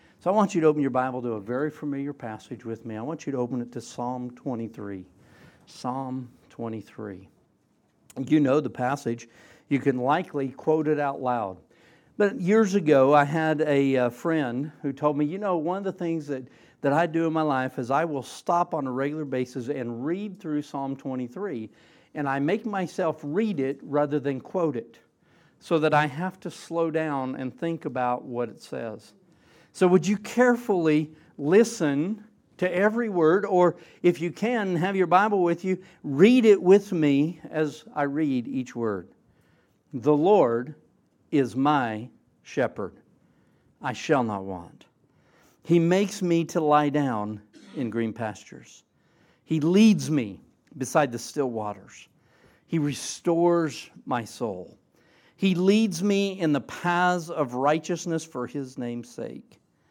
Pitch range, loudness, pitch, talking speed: 130-170 Hz, -25 LUFS, 150 Hz, 165 wpm